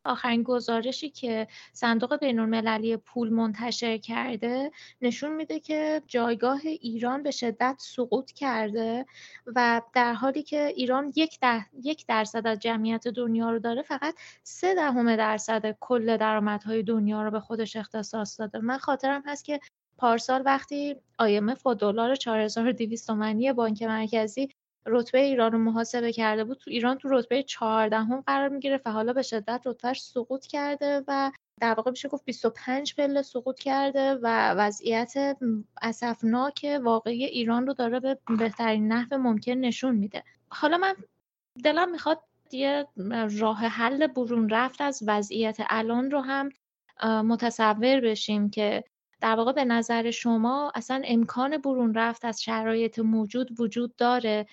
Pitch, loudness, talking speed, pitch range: 240 Hz, -27 LUFS, 140 wpm, 225-270 Hz